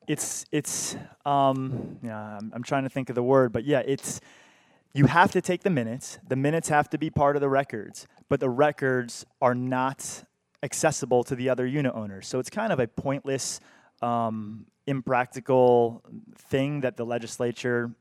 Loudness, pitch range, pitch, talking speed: -26 LUFS, 120-145 Hz, 130 Hz, 175 wpm